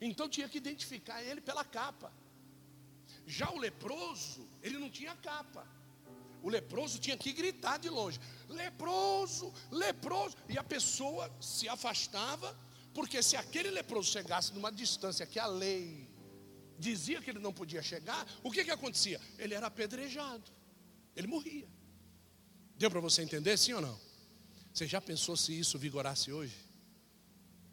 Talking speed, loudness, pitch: 145 wpm, -37 LUFS, 200 Hz